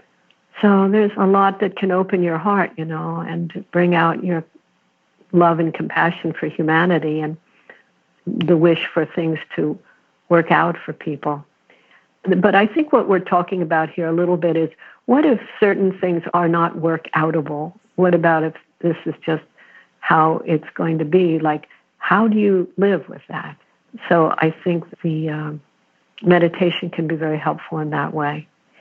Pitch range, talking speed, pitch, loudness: 160-185 Hz, 170 wpm, 170 Hz, -19 LUFS